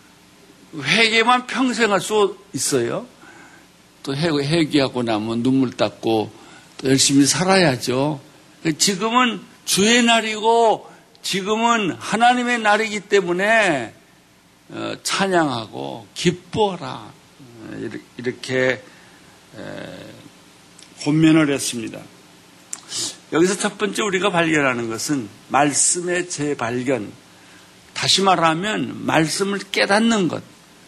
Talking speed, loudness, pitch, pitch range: 195 characters per minute, -19 LUFS, 170 Hz, 135-210 Hz